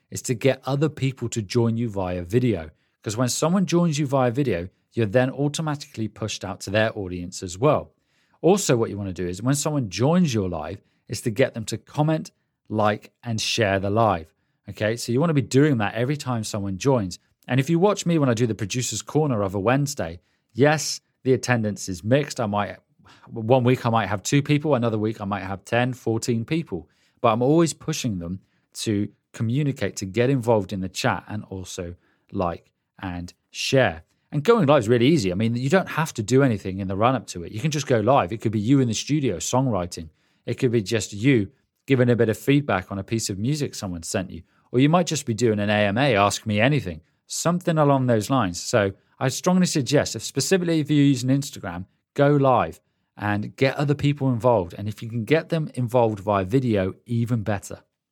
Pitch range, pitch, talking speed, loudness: 100-140 Hz, 120 Hz, 215 wpm, -23 LUFS